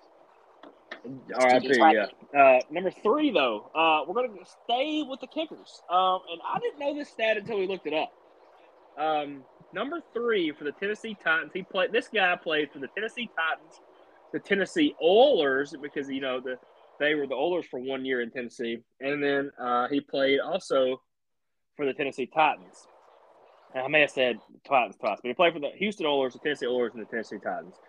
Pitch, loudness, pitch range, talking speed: 160 Hz, -27 LUFS, 135-220 Hz, 190 wpm